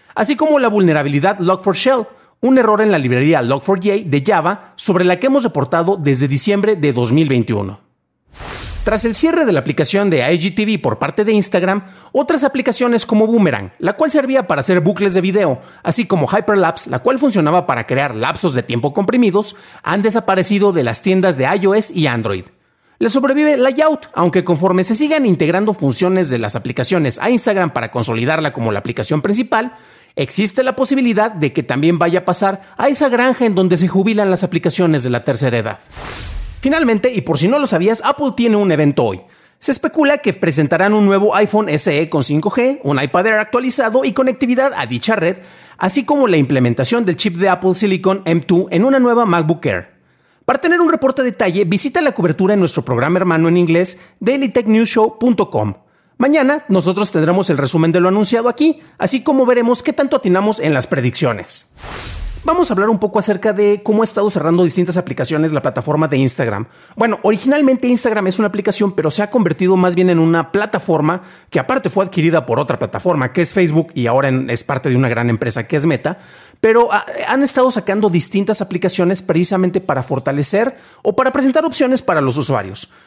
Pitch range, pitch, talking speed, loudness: 155-230 Hz, 190 Hz, 185 wpm, -14 LUFS